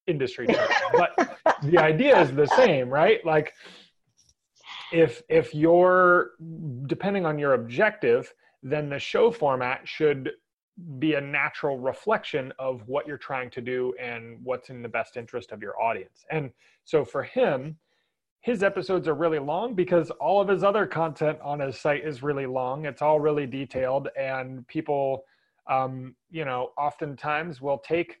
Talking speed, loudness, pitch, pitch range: 155 wpm, -25 LUFS, 150 Hz, 130-170 Hz